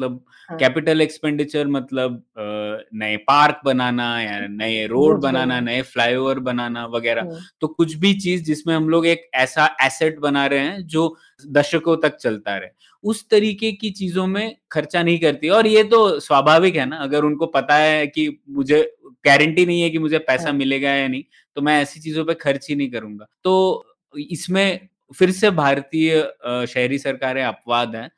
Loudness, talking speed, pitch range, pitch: -19 LUFS, 170 wpm, 130-170 Hz, 150 Hz